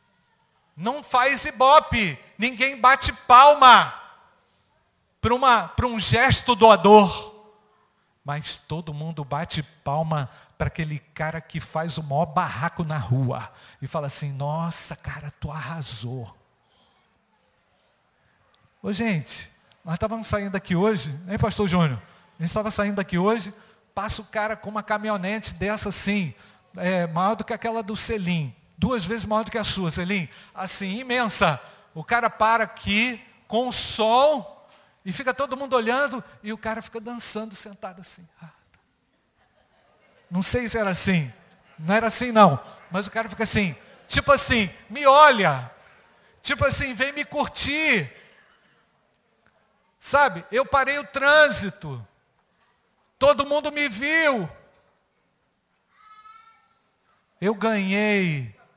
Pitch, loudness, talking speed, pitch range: 205 Hz, -22 LUFS, 130 wpm, 165-235 Hz